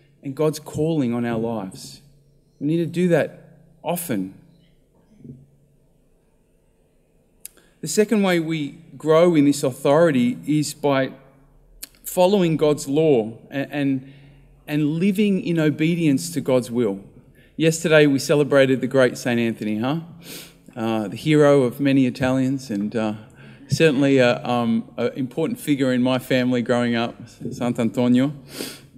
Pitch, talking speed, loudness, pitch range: 140 Hz, 125 wpm, -20 LUFS, 125-155 Hz